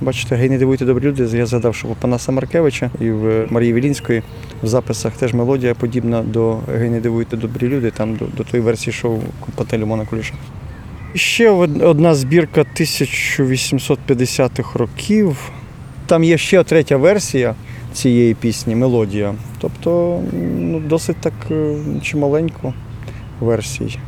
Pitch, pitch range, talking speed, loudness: 125 Hz, 115-140 Hz, 135 wpm, -16 LUFS